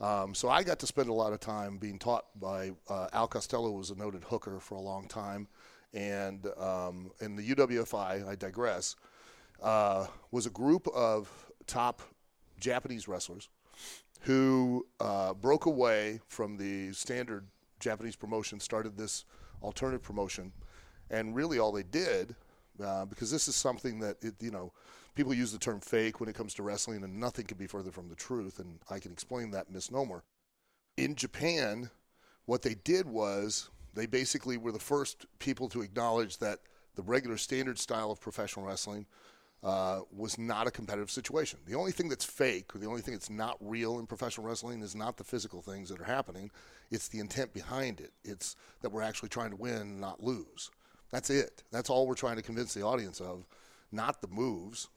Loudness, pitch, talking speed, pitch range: -35 LUFS, 110 Hz, 185 wpm, 100-120 Hz